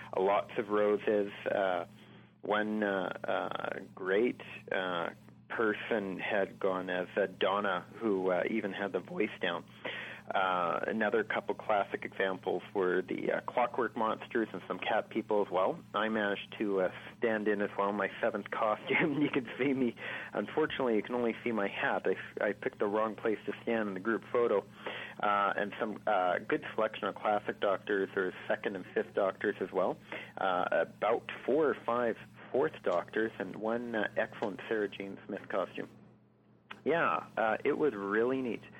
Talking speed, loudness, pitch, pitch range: 170 wpm, -33 LUFS, 105 Hz, 100-115 Hz